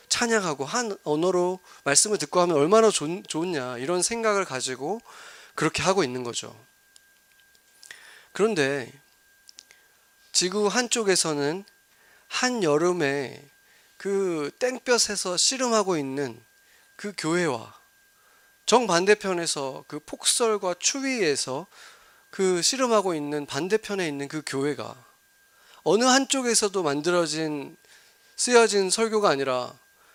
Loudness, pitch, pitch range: -24 LUFS, 190 Hz, 155-230 Hz